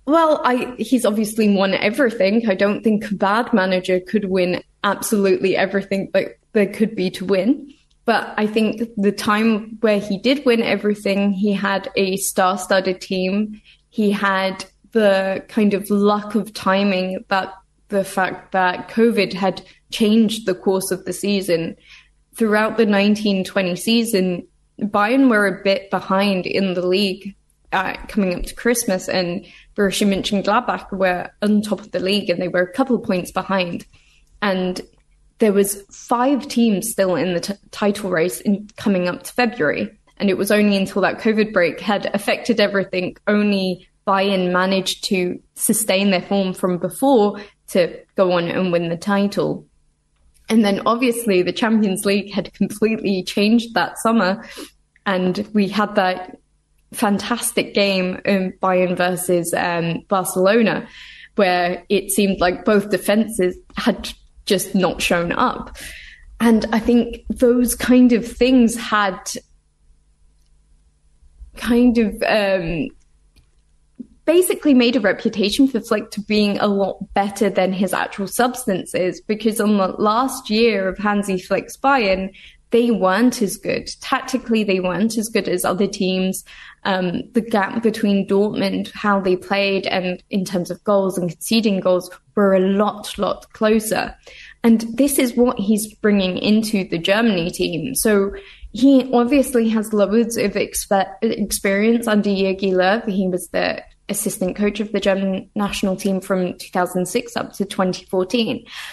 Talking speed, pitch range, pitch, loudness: 150 wpm, 185-225 Hz, 200 Hz, -19 LUFS